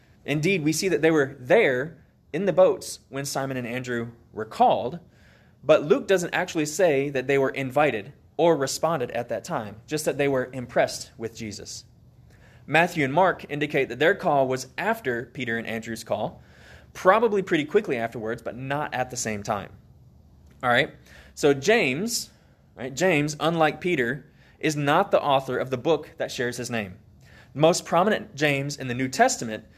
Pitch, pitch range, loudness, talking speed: 135 Hz, 115-155 Hz, -24 LUFS, 175 wpm